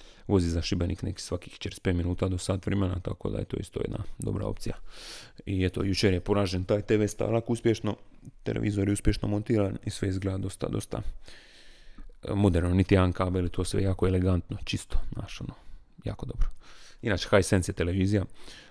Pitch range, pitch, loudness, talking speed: 95-105 Hz, 100 Hz, -29 LUFS, 165 wpm